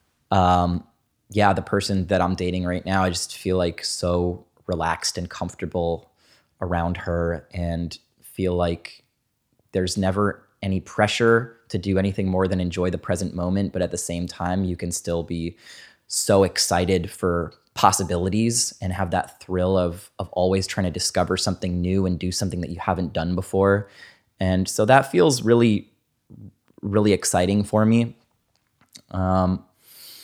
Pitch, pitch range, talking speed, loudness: 95 Hz, 90-100 Hz, 155 wpm, -23 LUFS